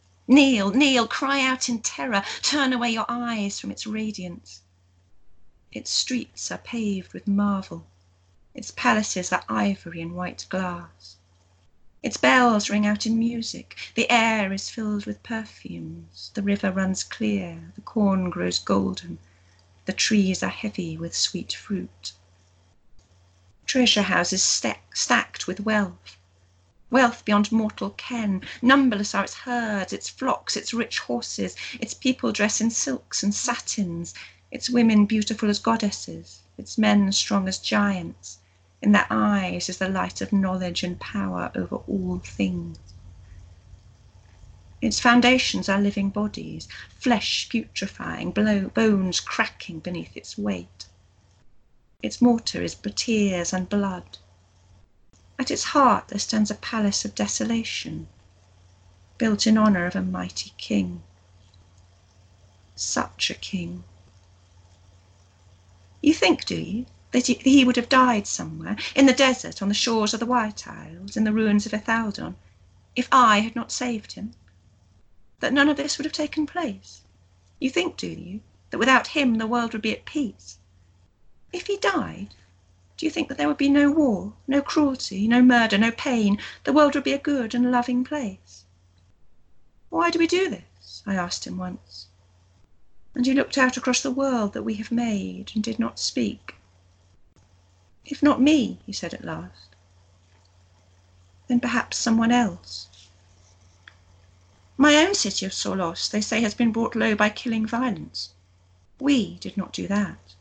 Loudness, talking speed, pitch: -23 LUFS, 150 wpm, 190 Hz